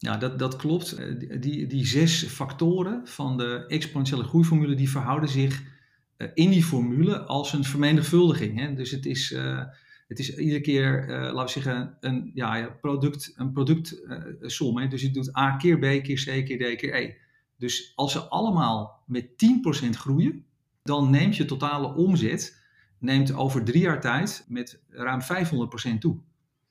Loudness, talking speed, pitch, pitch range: -25 LUFS, 155 wpm, 135 Hz, 130-155 Hz